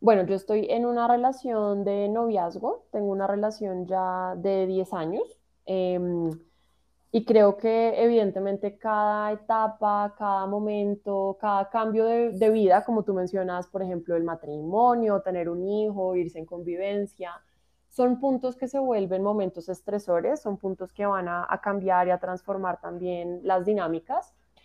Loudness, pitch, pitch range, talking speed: -26 LUFS, 200 Hz, 185-215 Hz, 150 wpm